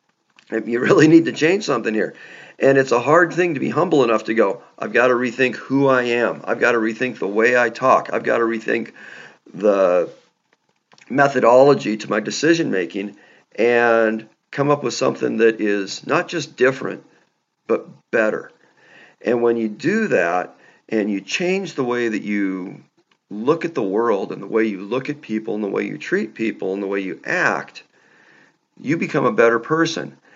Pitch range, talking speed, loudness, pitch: 110-135 Hz, 185 wpm, -19 LUFS, 115 Hz